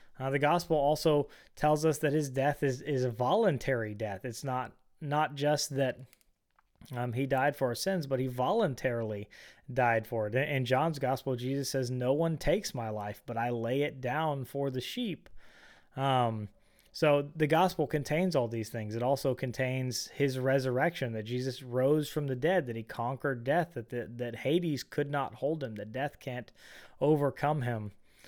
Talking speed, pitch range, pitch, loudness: 180 wpm, 120-145 Hz, 130 Hz, -32 LUFS